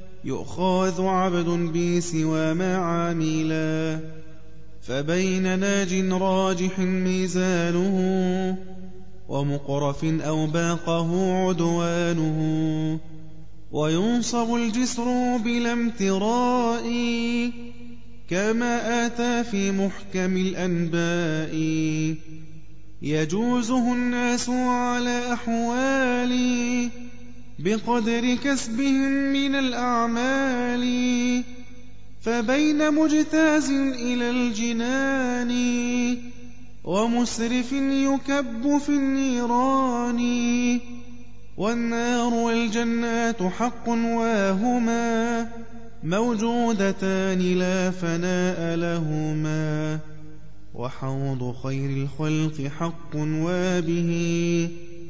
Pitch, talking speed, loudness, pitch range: 190 Hz, 55 wpm, -24 LUFS, 160-240 Hz